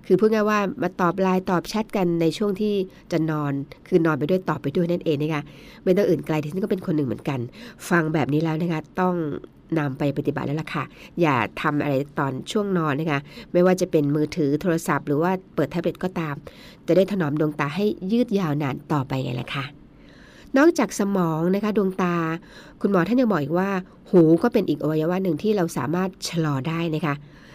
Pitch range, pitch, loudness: 150-185 Hz, 170 Hz, -23 LUFS